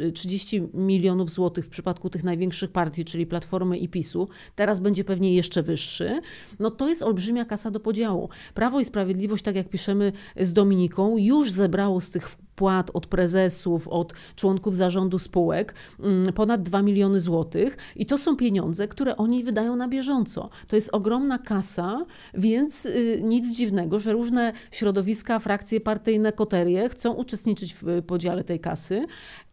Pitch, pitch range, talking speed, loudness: 200 Hz, 180-220 Hz, 150 wpm, -25 LUFS